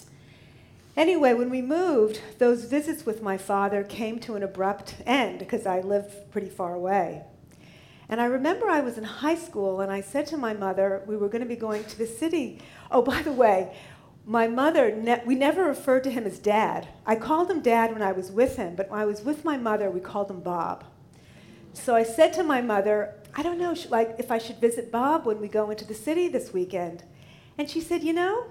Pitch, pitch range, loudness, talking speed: 225 Hz, 200-280 Hz, -26 LUFS, 220 wpm